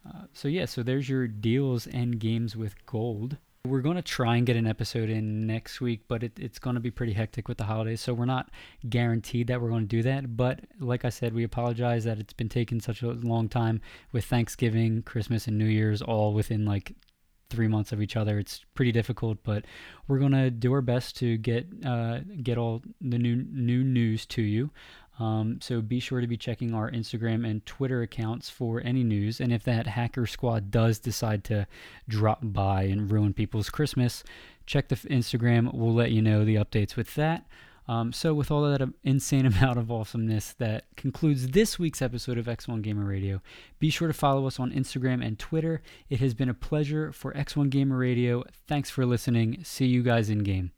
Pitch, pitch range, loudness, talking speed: 120 Hz, 110-130 Hz, -28 LUFS, 205 wpm